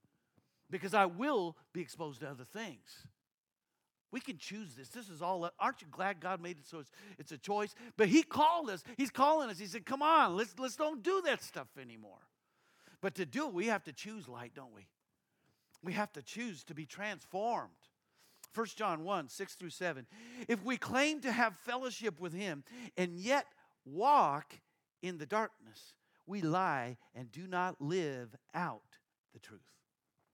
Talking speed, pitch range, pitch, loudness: 180 wpm, 160-235 Hz, 195 Hz, -36 LUFS